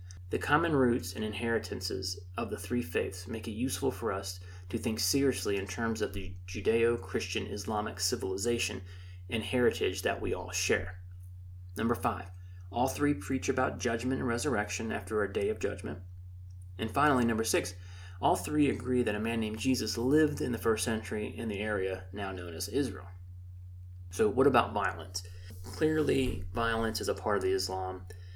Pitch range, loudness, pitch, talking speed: 90-115 Hz, -32 LUFS, 100 Hz, 170 wpm